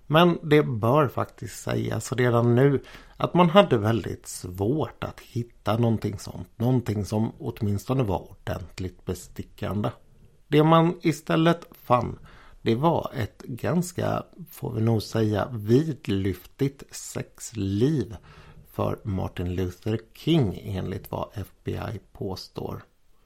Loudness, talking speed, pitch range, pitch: -26 LUFS, 115 wpm, 100-140 Hz, 115 Hz